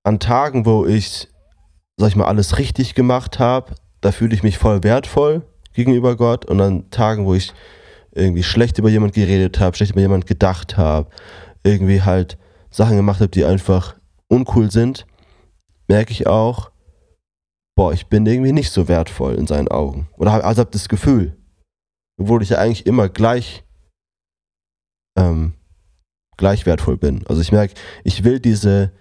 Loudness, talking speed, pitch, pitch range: -16 LUFS, 165 wpm, 95 Hz, 85-110 Hz